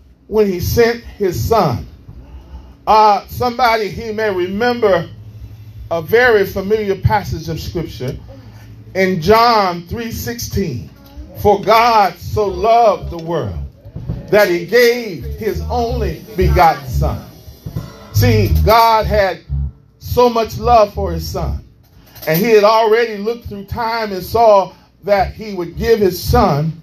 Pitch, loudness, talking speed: 195 Hz, -15 LUFS, 125 wpm